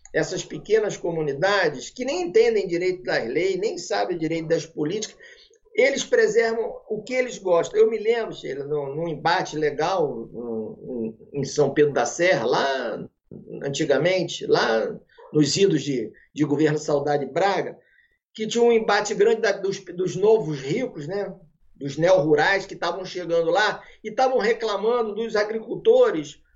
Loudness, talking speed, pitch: -23 LUFS, 155 wpm, 200 Hz